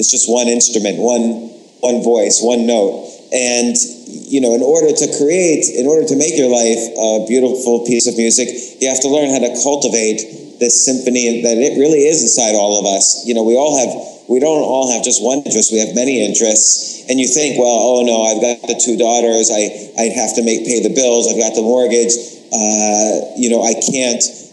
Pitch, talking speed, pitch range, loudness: 120 Hz, 215 wpm, 110-125 Hz, -13 LUFS